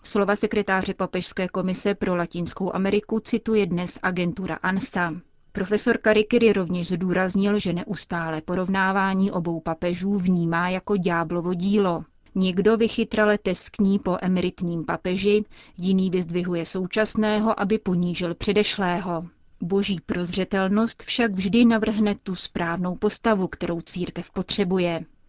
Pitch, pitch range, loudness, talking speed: 190 Hz, 180-205 Hz, -23 LUFS, 110 wpm